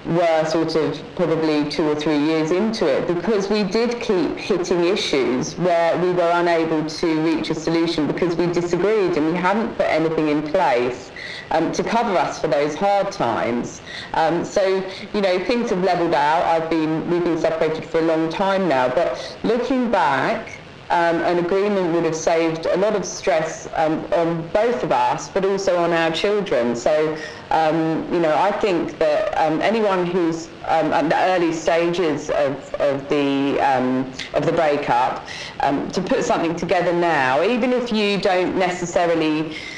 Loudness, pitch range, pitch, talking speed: -20 LUFS, 160-185 Hz, 165 Hz, 175 wpm